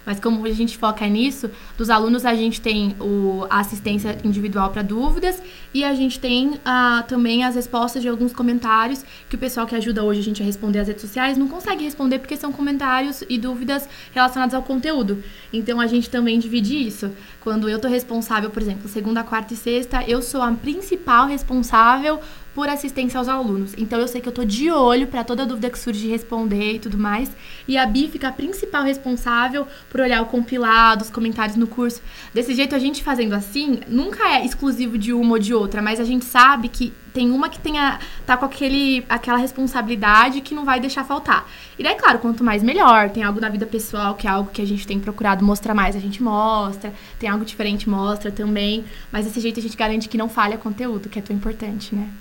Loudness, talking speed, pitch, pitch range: -20 LUFS, 215 wpm, 235 Hz, 215-260 Hz